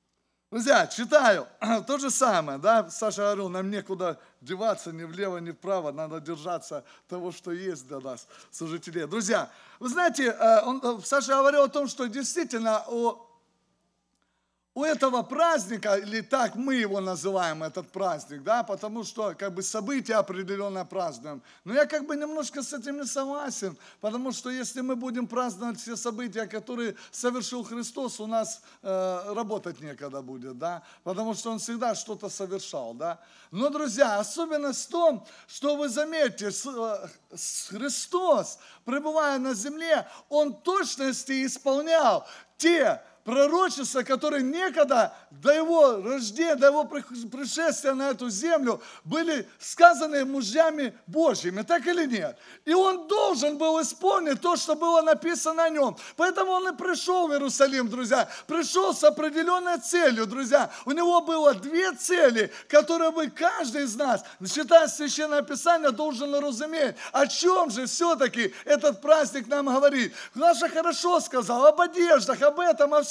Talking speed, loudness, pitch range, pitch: 145 wpm, -26 LUFS, 220-310 Hz, 270 Hz